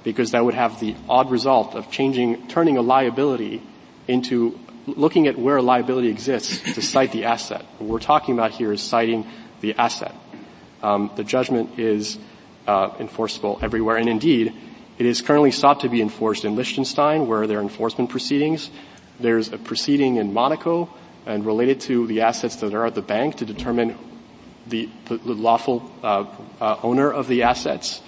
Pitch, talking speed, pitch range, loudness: 120 Hz, 175 wpm, 115-130 Hz, -21 LUFS